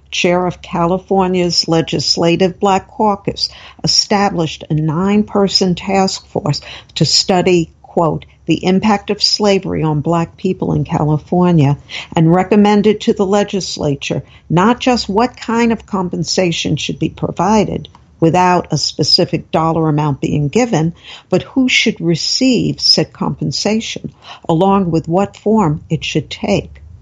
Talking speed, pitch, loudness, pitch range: 125 wpm, 180 Hz, -14 LUFS, 160-200 Hz